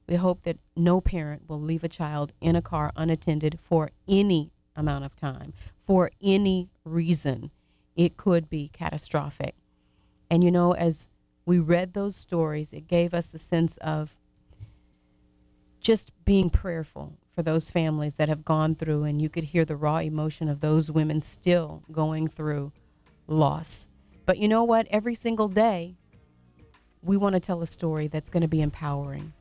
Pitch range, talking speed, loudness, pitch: 150-175 Hz, 165 wpm, -26 LUFS, 160 Hz